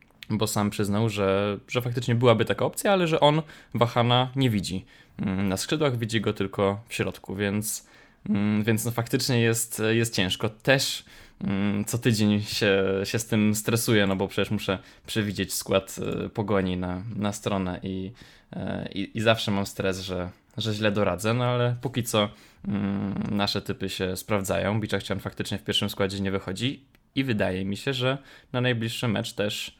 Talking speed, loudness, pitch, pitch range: 165 wpm, -26 LUFS, 105 Hz, 100-115 Hz